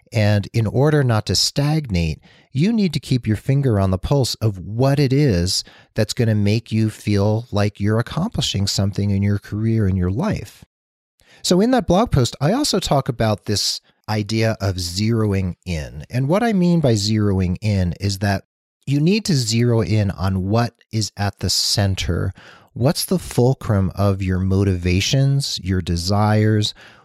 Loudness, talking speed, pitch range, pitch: -19 LUFS, 170 wpm, 95-130 Hz, 105 Hz